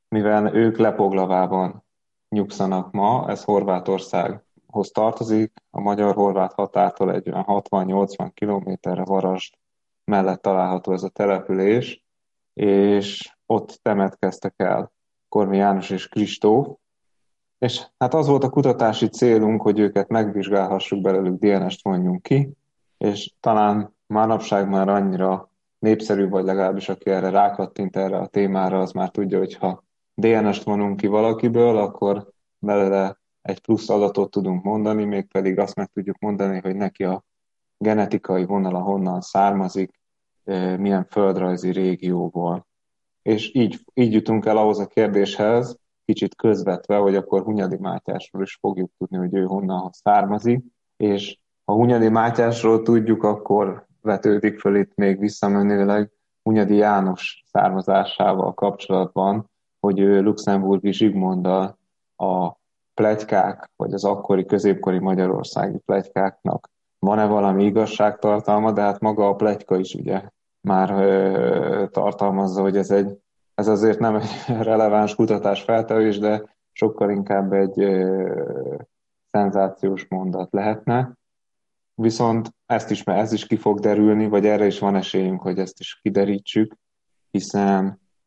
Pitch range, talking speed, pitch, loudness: 95-105 Hz, 130 wpm, 100 Hz, -21 LUFS